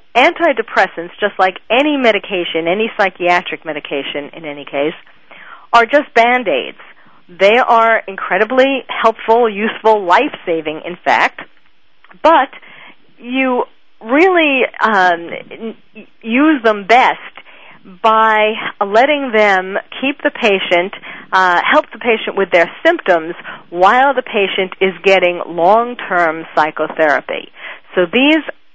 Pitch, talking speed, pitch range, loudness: 210 Hz, 105 wpm, 175-240 Hz, -13 LUFS